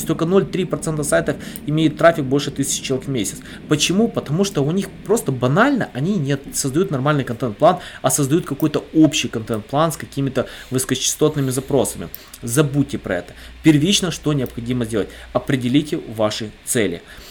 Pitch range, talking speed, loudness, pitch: 130-165 Hz, 140 wpm, -19 LUFS, 145 Hz